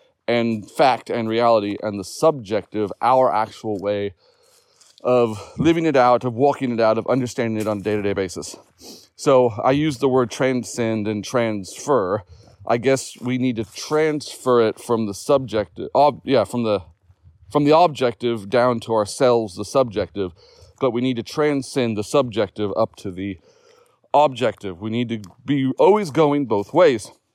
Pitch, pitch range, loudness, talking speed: 115 Hz, 105-130 Hz, -20 LUFS, 160 wpm